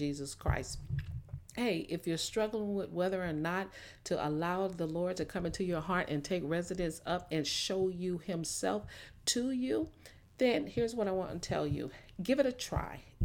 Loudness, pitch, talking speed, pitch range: -35 LUFS, 180 Hz, 185 wpm, 160-190 Hz